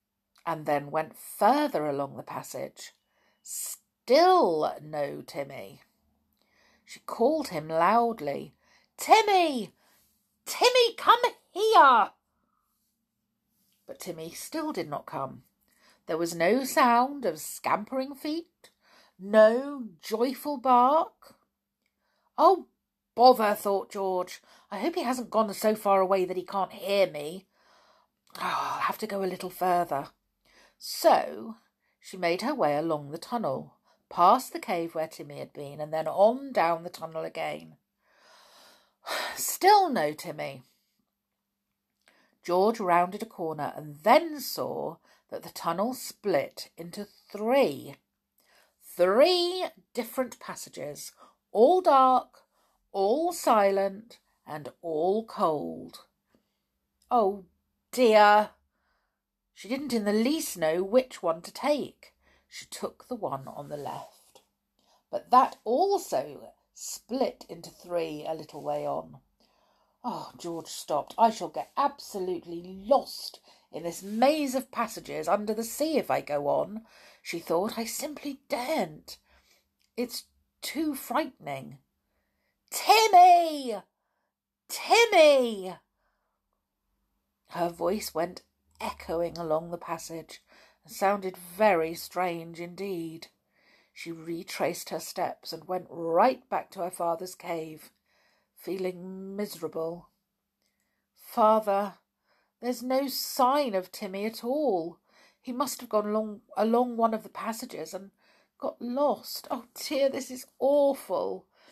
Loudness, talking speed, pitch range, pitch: -27 LUFS, 115 wpm, 170-260 Hz, 205 Hz